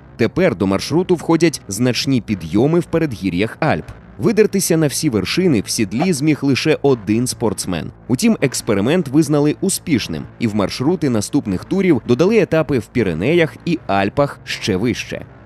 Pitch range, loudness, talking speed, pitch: 110-170 Hz, -17 LUFS, 140 wpm, 145 Hz